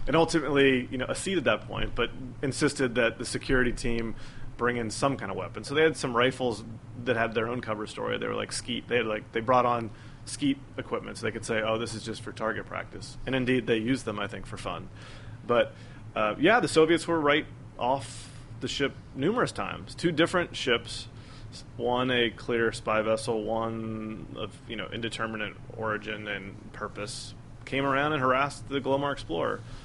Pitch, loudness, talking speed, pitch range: 120 Hz, -29 LUFS, 195 wpm, 110-130 Hz